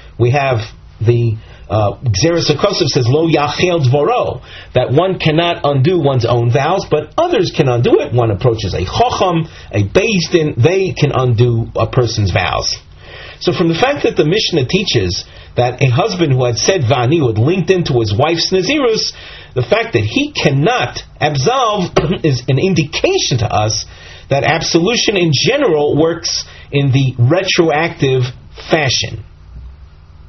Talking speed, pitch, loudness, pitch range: 145 wpm, 135 Hz, -14 LUFS, 115-165 Hz